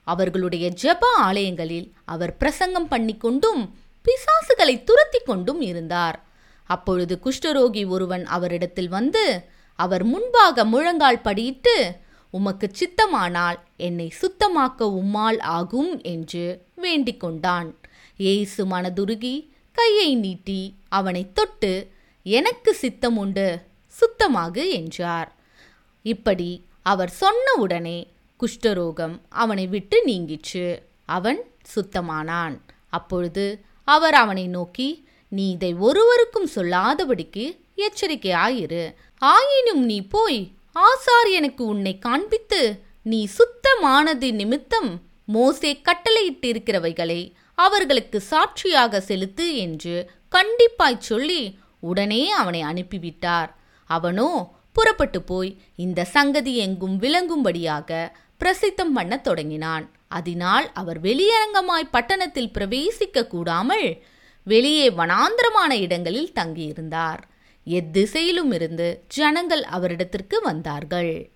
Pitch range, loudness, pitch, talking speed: 180-300 Hz, -21 LUFS, 215 Hz, 85 wpm